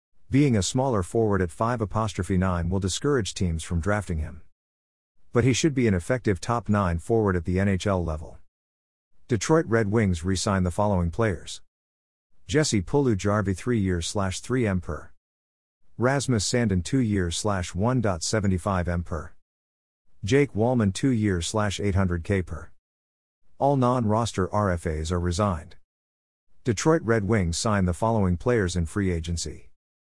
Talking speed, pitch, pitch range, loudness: 155 wpm, 95 Hz, 85-110 Hz, -25 LUFS